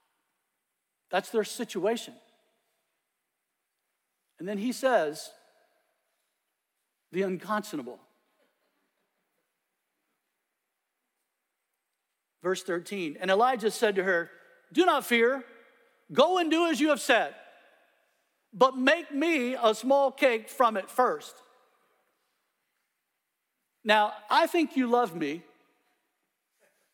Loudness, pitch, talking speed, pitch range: -27 LUFS, 235 Hz, 90 wpm, 205-270 Hz